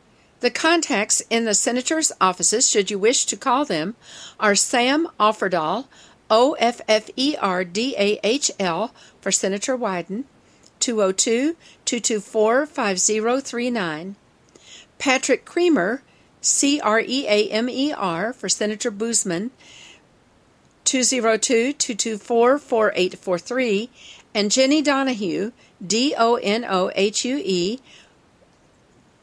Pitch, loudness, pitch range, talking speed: 225 Hz, -20 LUFS, 205-260 Hz, 85 wpm